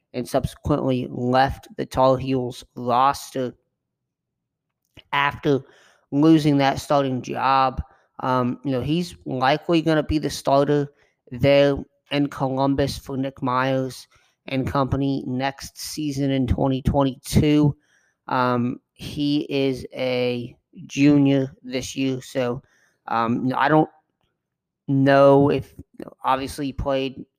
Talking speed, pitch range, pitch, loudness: 110 wpm, 130-140 Hz, 135 Hz, -22 LUFS